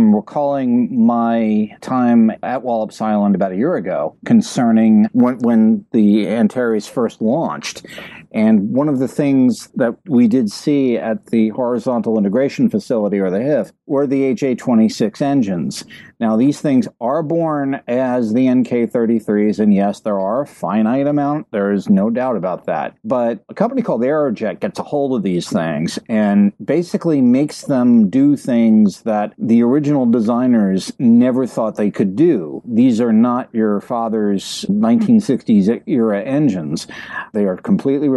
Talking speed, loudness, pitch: 150 wpm, -16 LUFS, 140 Hz